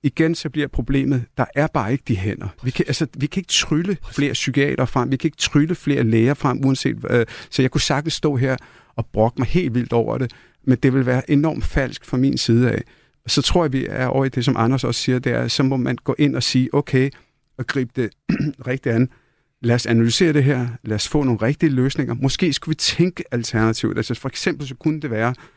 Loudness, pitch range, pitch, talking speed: -20 LUFS, 125-145 Hz, 135 Hz, 245 wpm